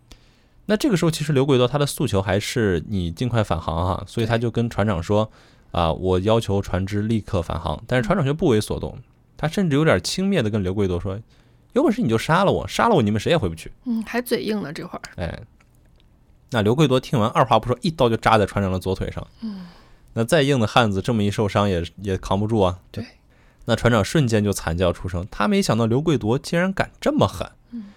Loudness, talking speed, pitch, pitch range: -21 LUFS, 330 characters per minute, 115 Hz, 95-145 Hz